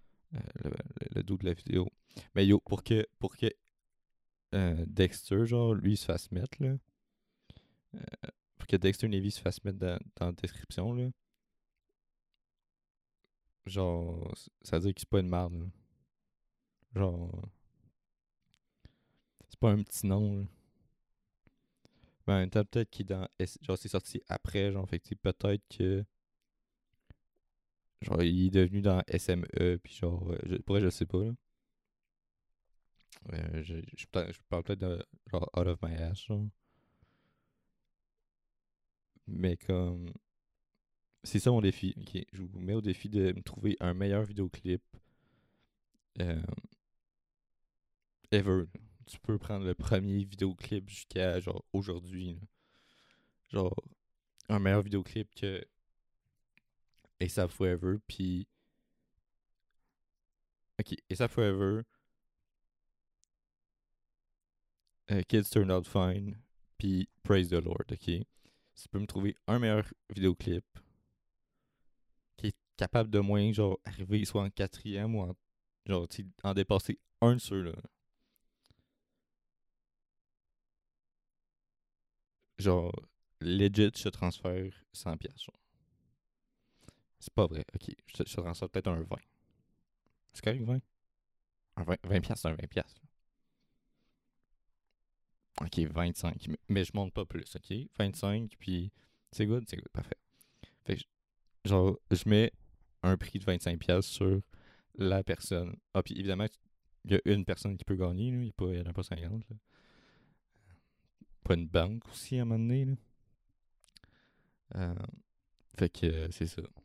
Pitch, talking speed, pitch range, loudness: 95 Hz, 130 wpm, 90-105 Hz, -34 LUFS